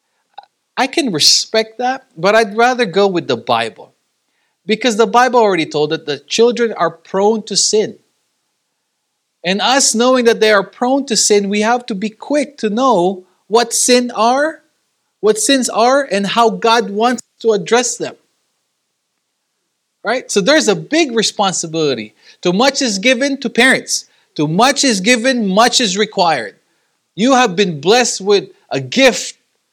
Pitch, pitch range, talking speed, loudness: 230 Hz, 205-250 Hz, 155 wpm, -13 LUFS